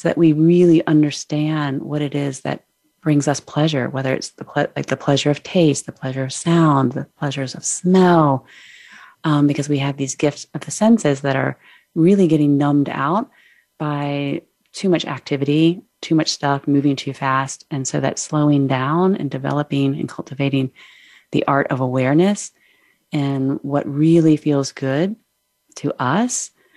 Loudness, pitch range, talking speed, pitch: -18 LUFS, 140-165 Hz, 165 wpm, 145 Hz